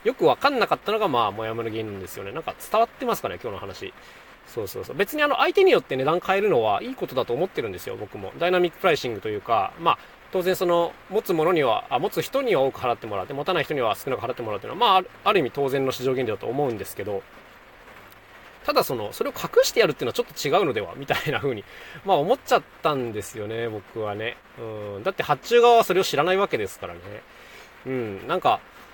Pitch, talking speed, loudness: 170 Hz, 510 characters per minute, -24 LUFS